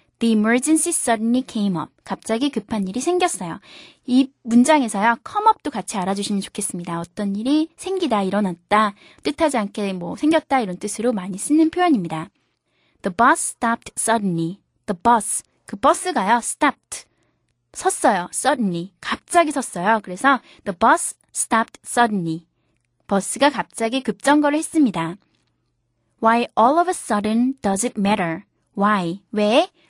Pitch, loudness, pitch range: 230 Hz, -20 LUFS, 200-285 Hz